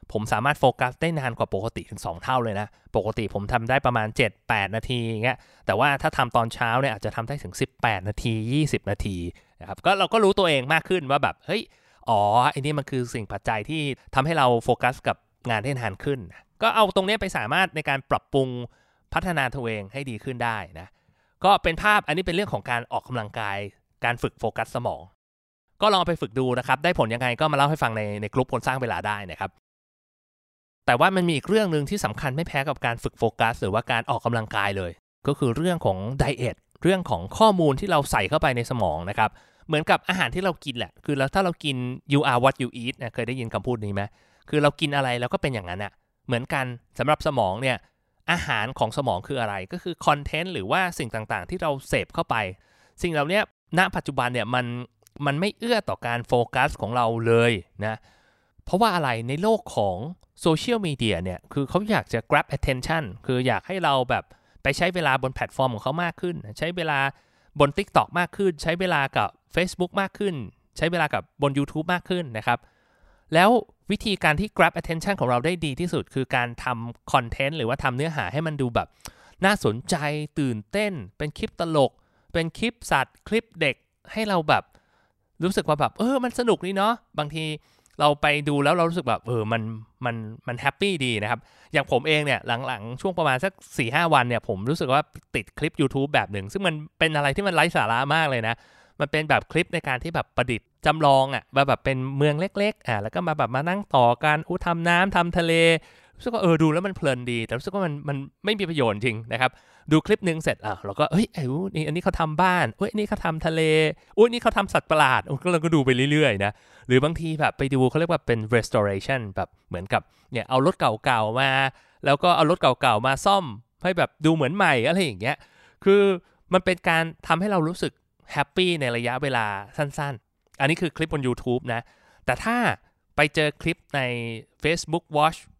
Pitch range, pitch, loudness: 120-170 Hz, 140 Hz, -24 LUFS